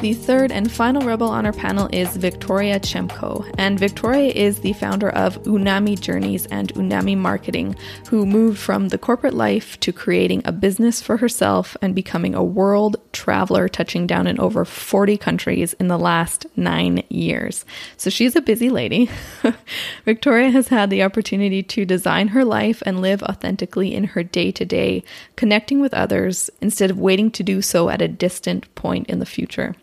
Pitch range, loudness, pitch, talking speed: 180-225 Hz, -19 LUFS, 200 Hz, 175 wpm